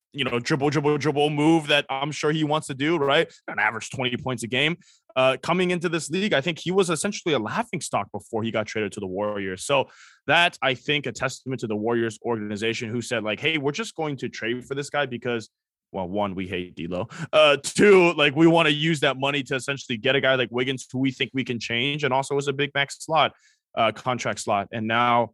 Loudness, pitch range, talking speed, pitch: -23 LUFS, 120-150 Hz, 240 wpm, 135 Hz